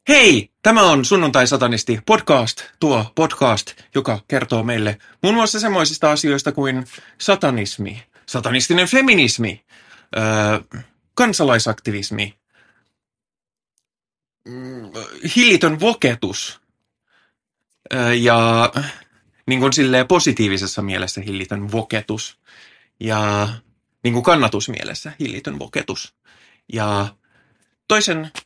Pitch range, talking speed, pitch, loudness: 110-150 Hz, 80 wpm, 120 Hz, -17 LUFS